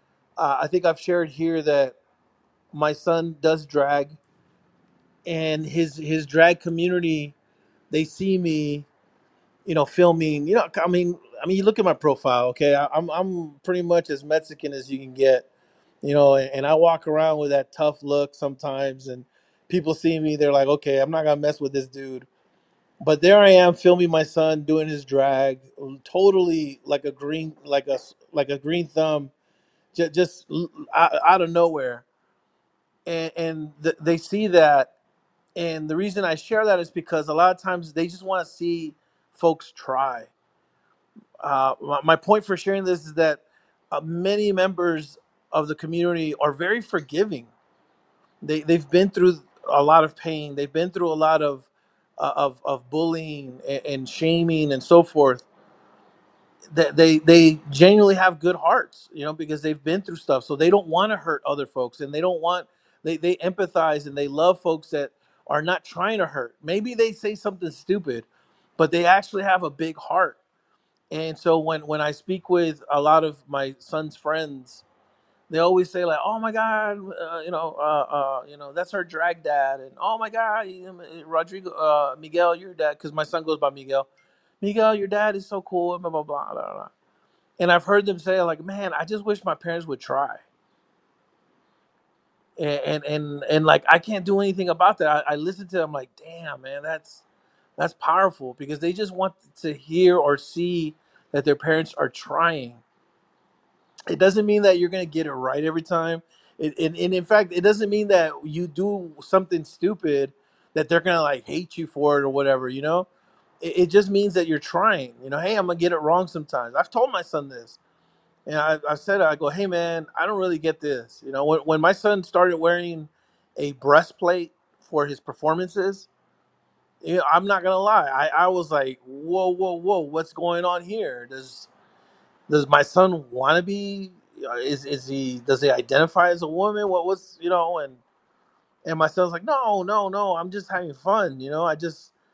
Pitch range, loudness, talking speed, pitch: 150-180 Hz, -22 LUFS, 190 wpm, 165 Hz